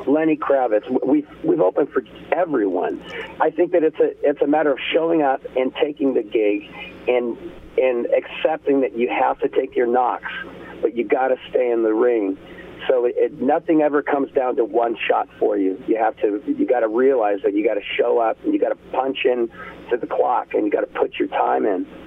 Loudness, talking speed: -20 LUFS, 225 wpm